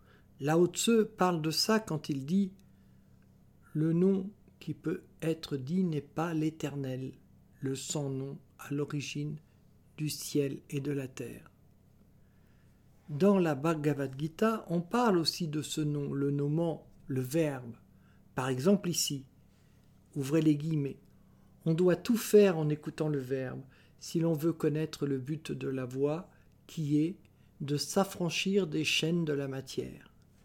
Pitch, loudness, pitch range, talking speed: 155 Hz, -32 LUFS, 140-170 Hz, 145 wpm